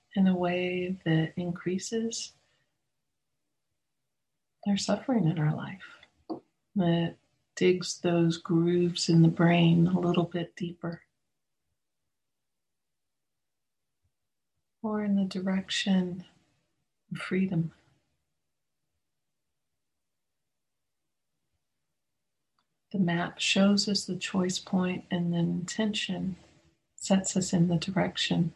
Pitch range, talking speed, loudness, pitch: 170-190 Hz, 90 wpm, -28 LUFS, 180 Hz